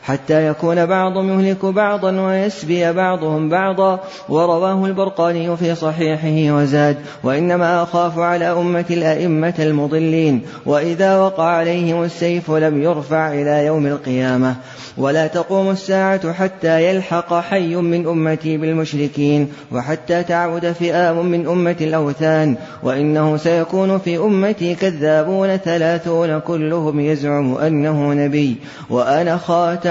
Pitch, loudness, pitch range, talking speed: 170 Hz, -17 LUFS, 155-175 Hz, 110 wpm